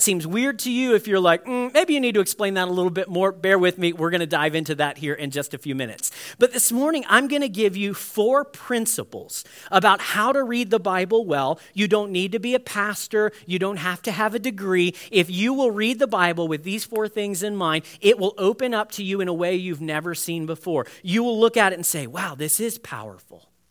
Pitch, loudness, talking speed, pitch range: 195 Hz, -22 LUFS, 255 wpm, 170-225 Hz